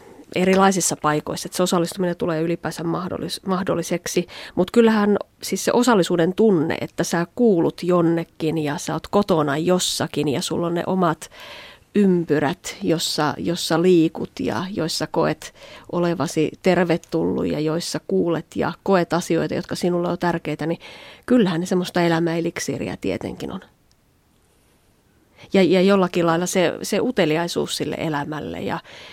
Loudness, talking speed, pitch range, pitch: -21 LUFS, 130 wpm, 160-185 Hz, 170 Hz